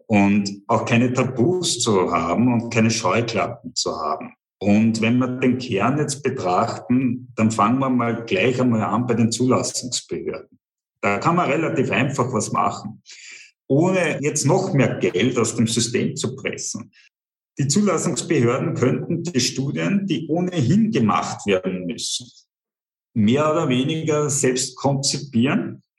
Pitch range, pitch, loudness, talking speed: 115-150 Hz, 125 Hz, -20 LUFS, 140 wpm